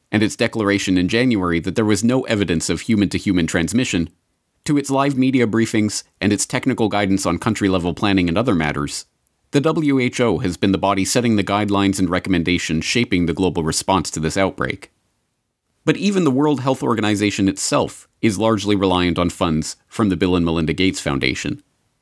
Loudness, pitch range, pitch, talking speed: -19 LUFS, 90-115 Hz, 100 Hz, 185 wpm